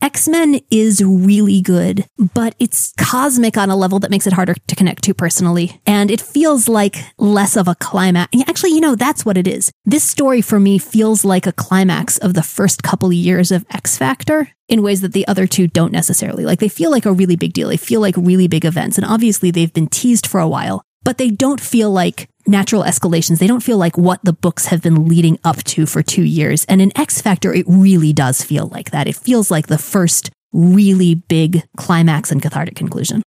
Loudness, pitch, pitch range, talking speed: -13 LUFS, 190 Hz, 170-215 Hz, 225 wpm